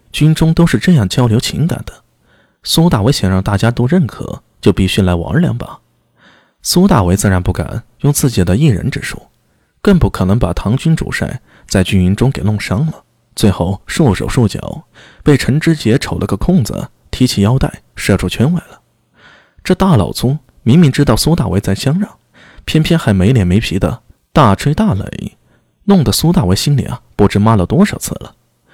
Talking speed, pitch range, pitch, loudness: 265 characters per minute, 100-150 Hz, 115 Hz, -13 LUFS